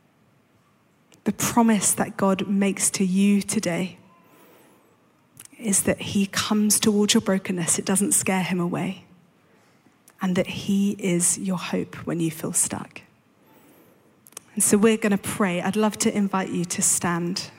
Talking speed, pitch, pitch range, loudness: 145 wpm, 195 Hz, 185-210 Hz, -22 LUFS